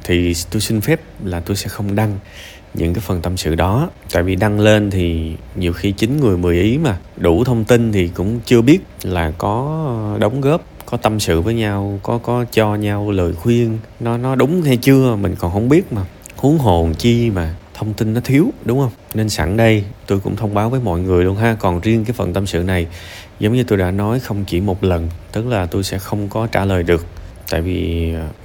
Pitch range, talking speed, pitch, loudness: 90-115 Hz, 230 wpm, 105 Hz, -17 LUFS